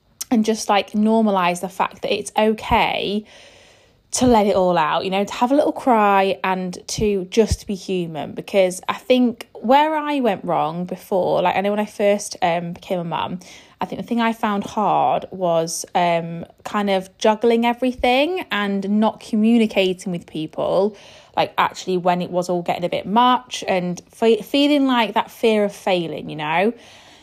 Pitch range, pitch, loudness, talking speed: 185-230 Hz, 205 Hz, -20 LUFS, 180 wpm